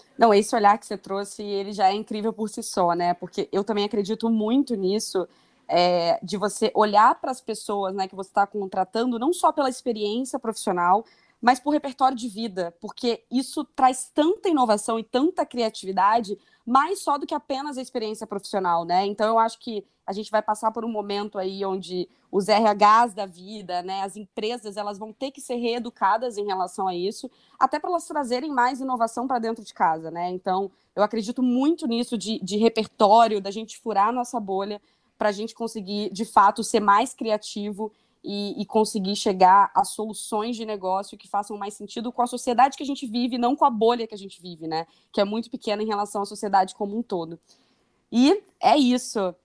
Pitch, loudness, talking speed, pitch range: 215 Hz, -24 LUFS, 200 wpm, 200-245 Hz